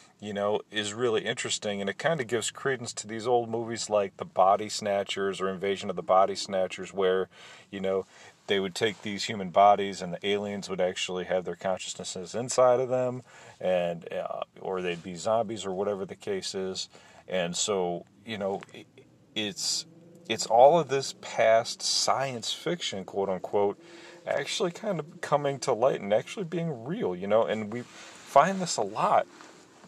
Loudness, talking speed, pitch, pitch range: -28 LUFS, 175 wpm, 105 Hz, 95-135 Hz